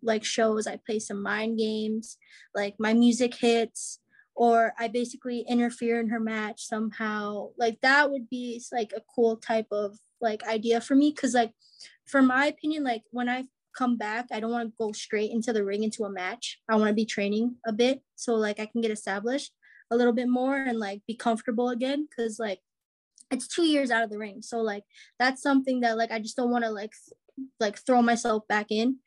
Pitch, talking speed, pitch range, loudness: 230 Hz, 210 wpm, 215-250 Hz, -27 LUFS